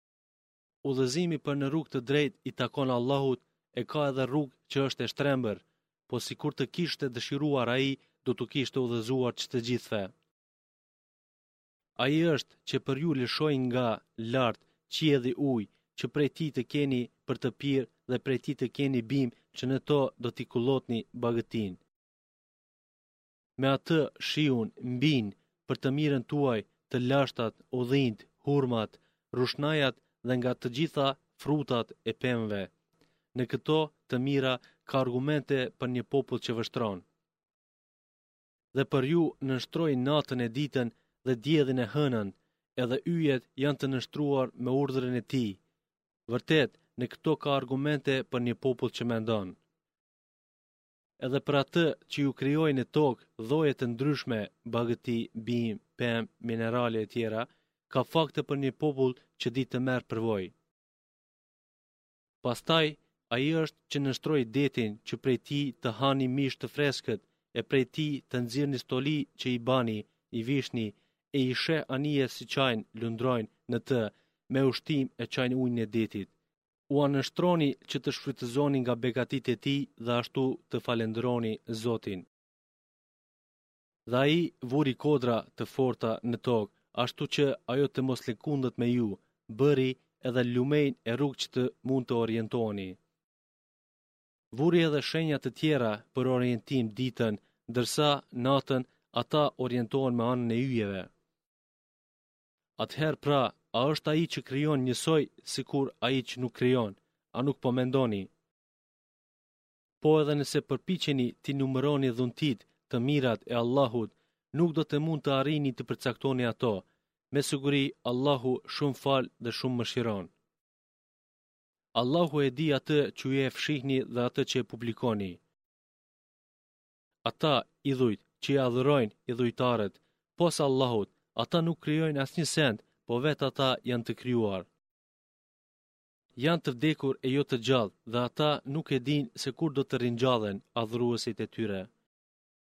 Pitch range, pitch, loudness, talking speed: 120-145 Hz, 130 Hz, -31 LUFS, 150 wpm